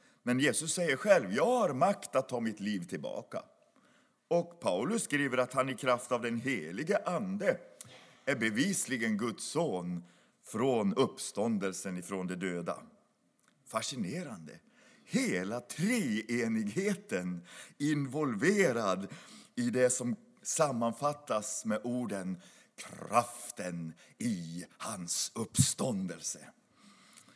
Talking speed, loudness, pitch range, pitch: 100 wpm, -33 LUFS, 95-145 Hz, 120 Hz